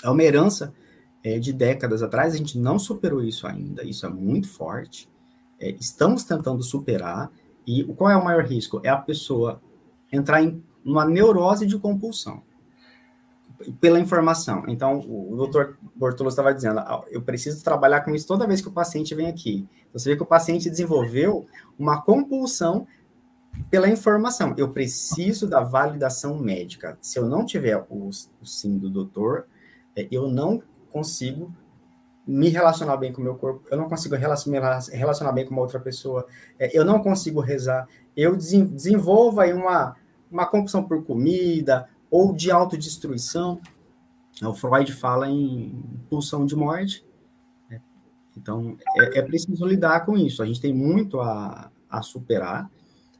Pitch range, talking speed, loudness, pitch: 125-170 Hz, 155 wpm, -22 LUFS, 140 Hz